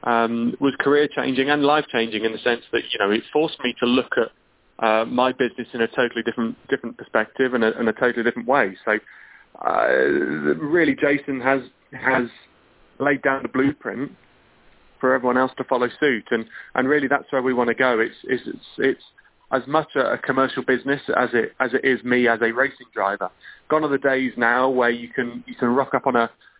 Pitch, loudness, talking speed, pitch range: 130 Hz, -21 LUFS, 210 wpm, 120-135 Hz